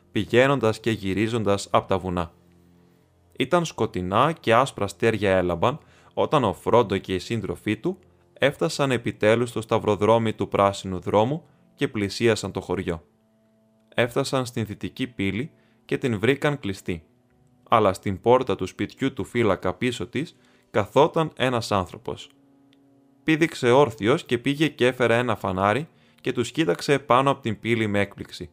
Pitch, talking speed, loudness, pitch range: 115 Hz, 140 wpm, -23 LUFS, 100-130 Hz